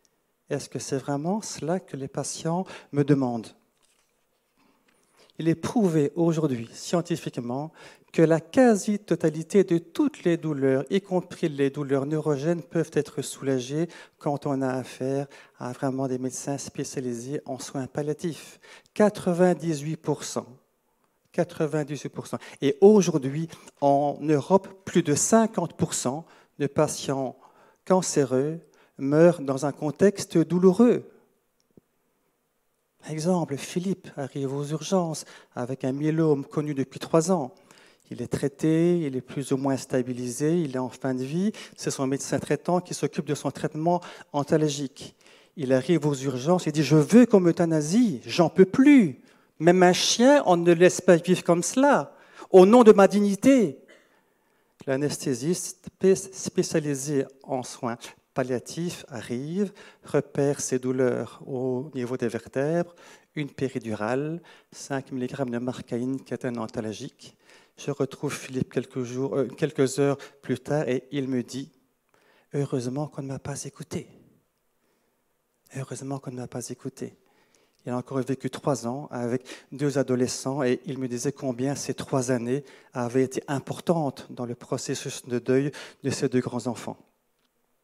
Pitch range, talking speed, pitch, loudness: 130-170 Hz, 140 wpm, 145 Hz, -25 LUFS